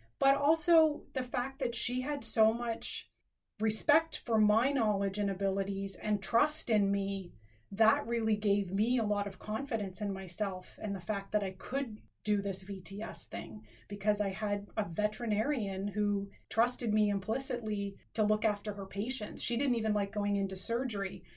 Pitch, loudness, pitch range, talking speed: 210 Hz, -33 LUFS, 200-230 Hz, 170 wpm